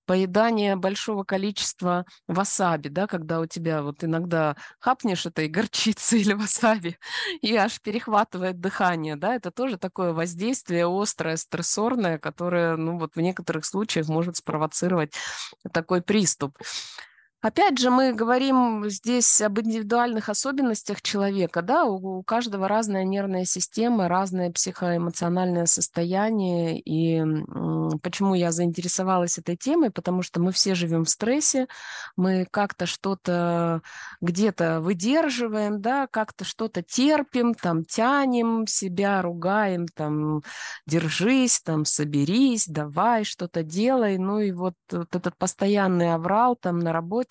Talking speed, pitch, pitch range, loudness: 125 wpm, 190 Hz, 170-220 Hz, -24 LUFS